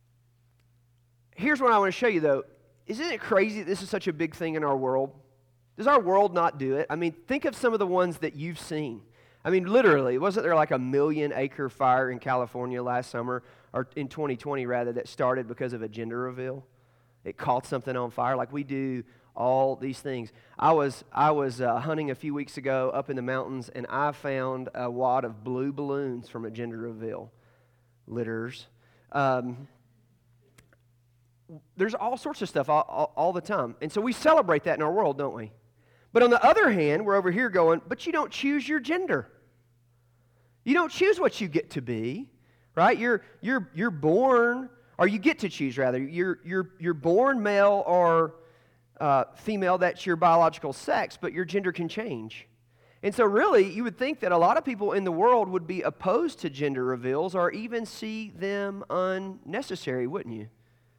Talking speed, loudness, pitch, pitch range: 195 wpm, -27 LUFS, 140 Hz, 125-190 Hz